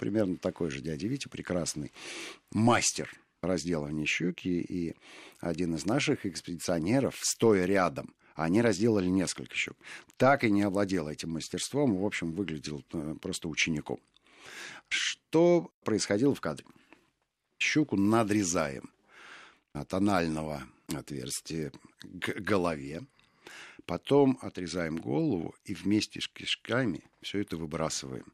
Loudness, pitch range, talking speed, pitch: -30 LUFS, 80-105 Hz, 110 wpm, 90 Hz